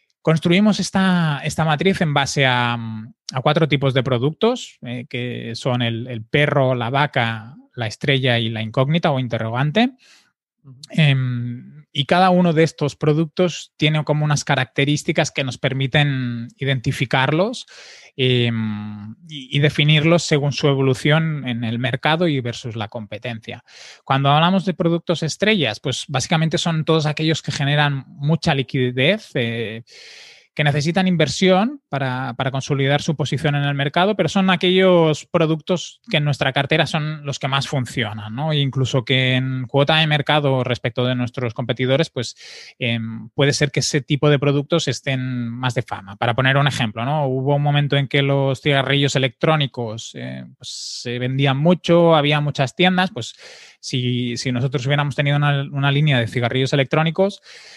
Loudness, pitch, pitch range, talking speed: -19 LUFS, 140 Hz, 130-160 Hz, 160 wpm